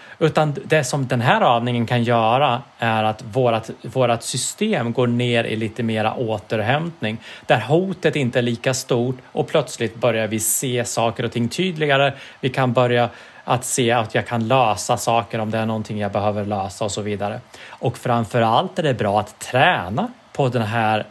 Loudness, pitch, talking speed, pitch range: -20 LUFS, 120 Hz, 180 wpm, 115-135 Hz